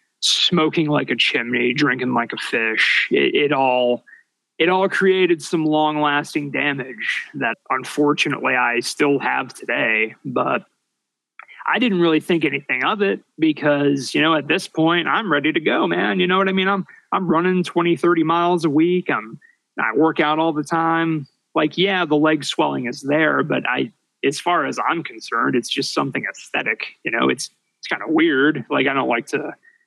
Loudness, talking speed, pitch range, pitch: -19 LUFS, 185 wpm, 145-180 Hz, 160 Hz